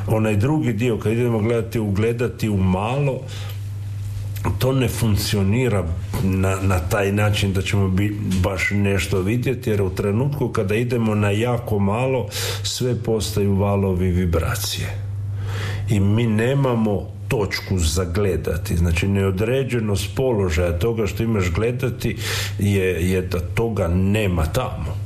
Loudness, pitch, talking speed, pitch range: -21 LUFS, 100 Hz, 125 wpm, 95-115 Hz